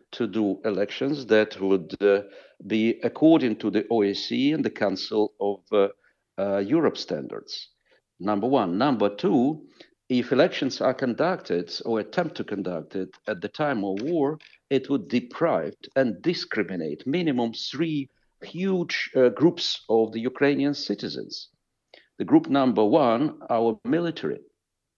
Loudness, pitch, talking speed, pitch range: -25 LUFS, 120 Hz, 135 wpm, 105-145 Hz